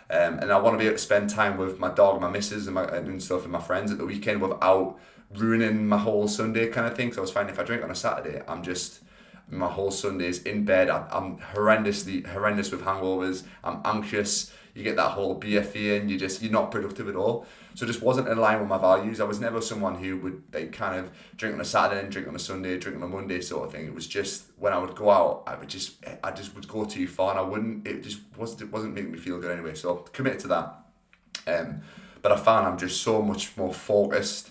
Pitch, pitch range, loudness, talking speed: 100 Hz, 95-105 Hz, -27 LUFS, 265 wpm